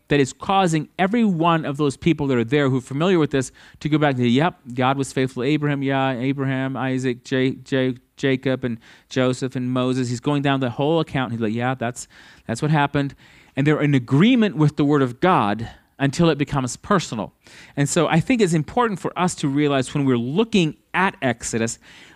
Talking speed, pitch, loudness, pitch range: 215 wpm, 140 Hz, -21 LUFS, 130-155 Hz